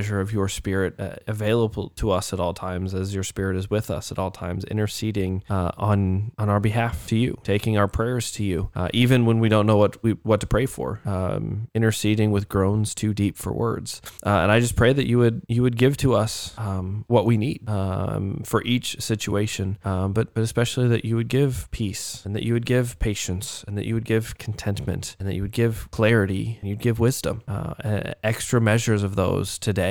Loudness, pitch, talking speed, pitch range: -23 LUFS, 105 Hz, 220 wpm, 95-115 Hz